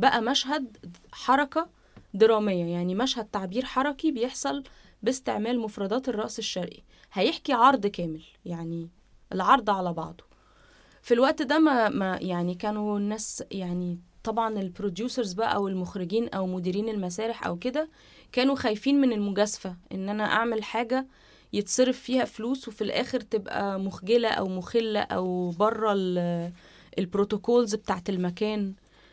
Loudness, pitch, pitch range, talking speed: -27 LUFS, 215 Hz, 190-245 Hz, 125 wpm